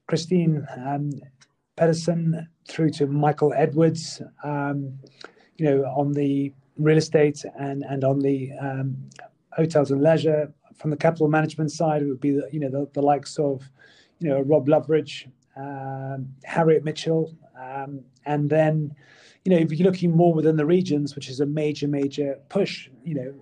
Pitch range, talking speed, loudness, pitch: 140-155 Hz, 165 wpm, -23 LUFS, 145 Hz